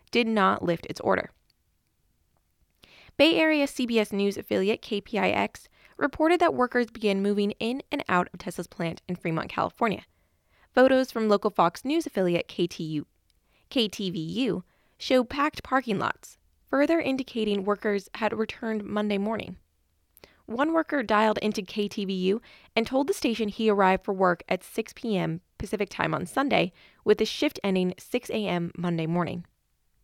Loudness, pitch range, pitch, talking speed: -27 LUFS, 180-245 Hz, 210 Hz, 145 wpm